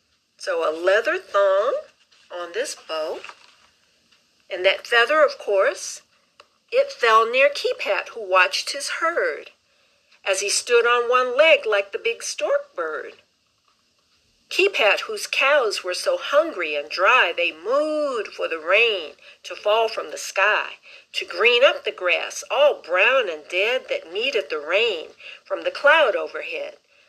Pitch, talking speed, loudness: 295 Hz, 145 wpm, -20 LUFS